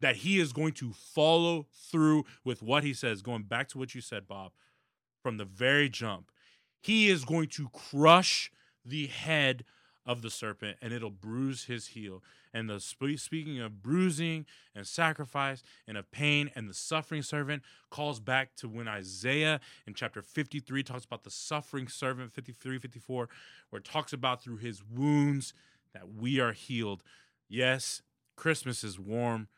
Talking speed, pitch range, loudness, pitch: 165 wpm, 115-150 Hz, -32 LUFS, 130 Hz